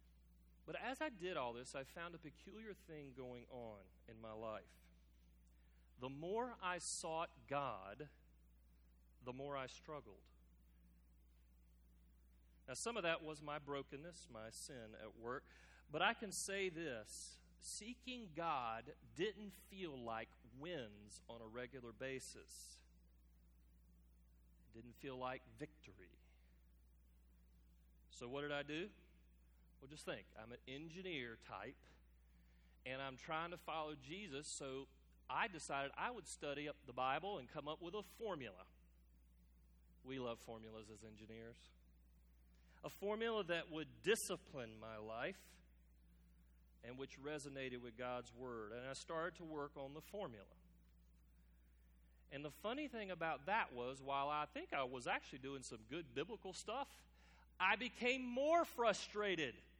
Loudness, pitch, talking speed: -47 LUFS, 120 Hz, 135 wpm